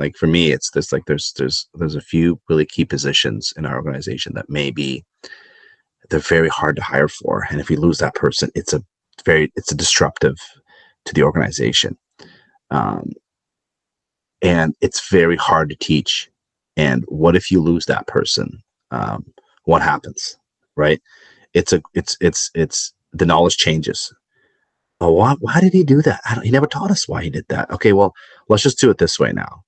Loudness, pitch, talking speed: -17 LUFS, 100 Hz, 185 wpm